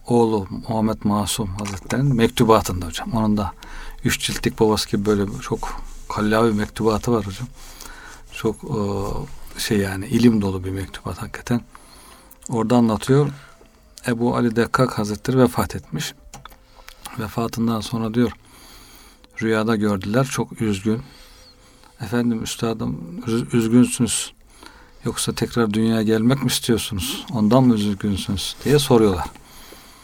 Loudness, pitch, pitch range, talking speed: -21 LUFS, 115 Hz, 105-120 Hz, 110 wpm